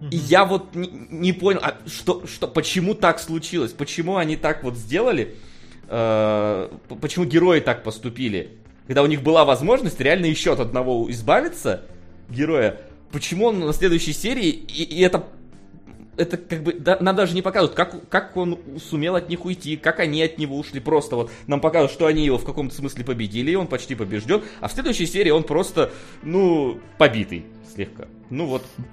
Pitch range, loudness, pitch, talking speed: 130-175 Hz, -21 LUFS, 155 Hz, 175 wpm